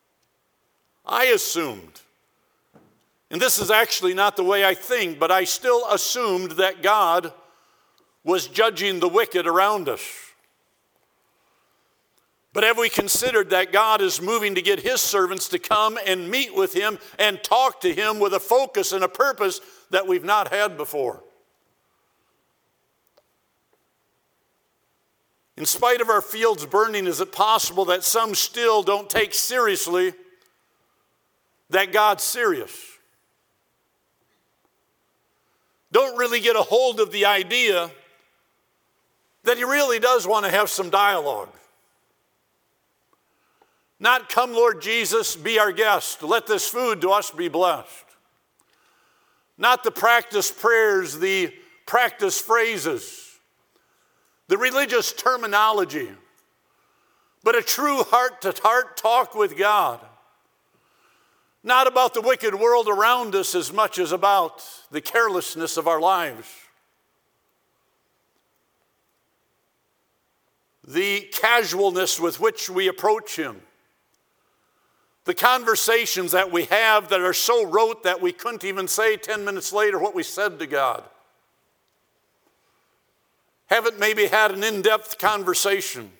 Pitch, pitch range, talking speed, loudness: 220 Hz, 195-255 Hz, 120 wpm, -21 LUFS